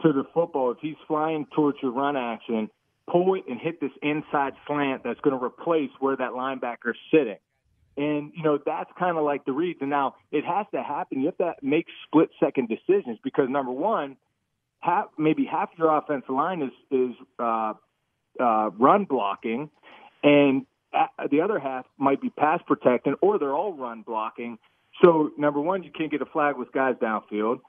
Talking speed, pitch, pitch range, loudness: 175 wpm, 140 Hz, 125-155 Hz, -25 LUFS